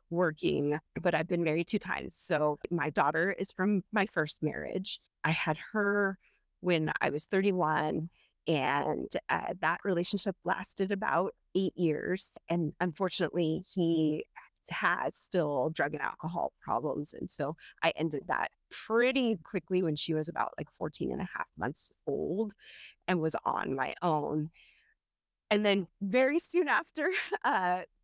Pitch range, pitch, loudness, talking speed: 160-200 Hz, 180 Hz, -32 LUFS, 145 wpm